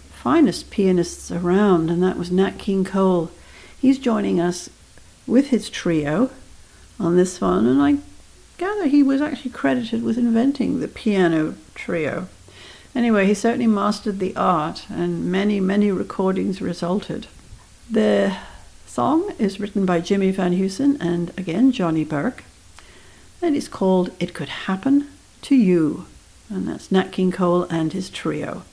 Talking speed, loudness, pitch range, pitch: 145 wpm, -20 LUFS, 175-230 Hz, 190 Hz